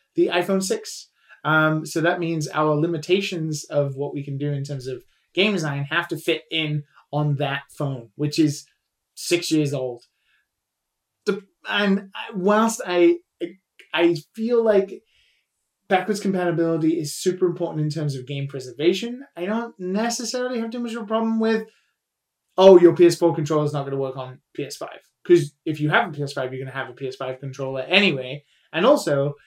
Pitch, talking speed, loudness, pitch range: 165 Hz, 170 wpm, -22 LUFS, 145-190 Hz